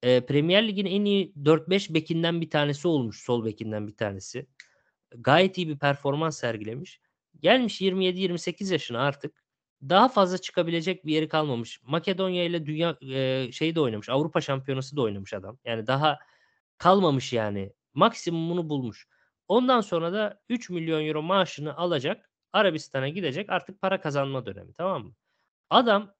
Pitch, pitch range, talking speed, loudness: 155 Hz, 130-185 Hz, 145 wpm, -26 LUFS